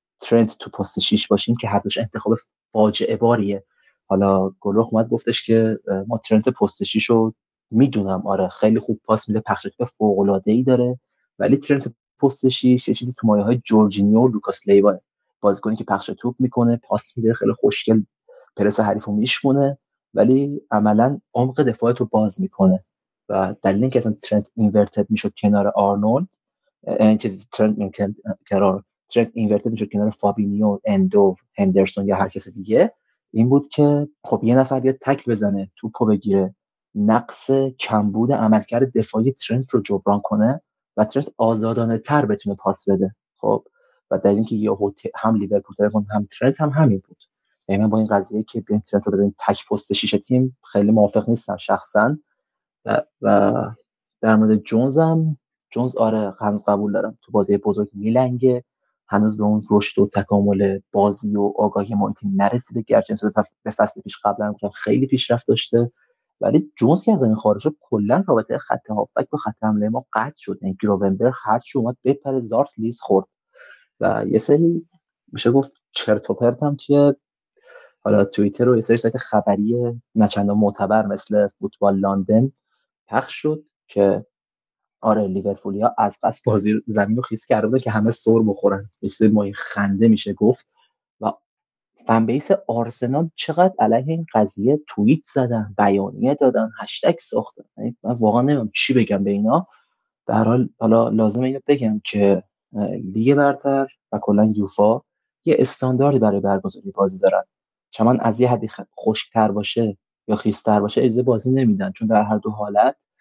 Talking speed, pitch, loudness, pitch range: 160 wpm, 110 Hz, -19 LUFS, 105-130 Hz